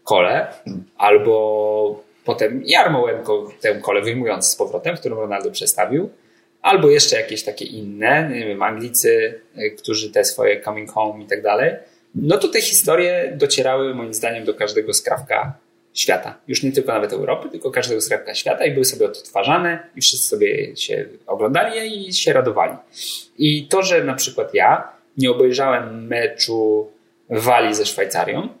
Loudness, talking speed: -18 LUFS, 150 wpm